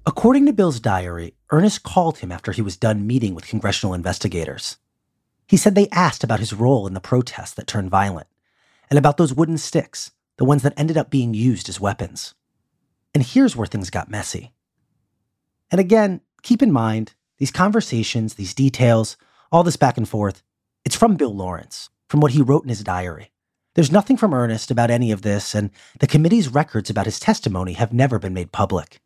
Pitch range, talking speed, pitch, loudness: 105-155 Hz, 190 wpm, 120 Hz, -19 LUFS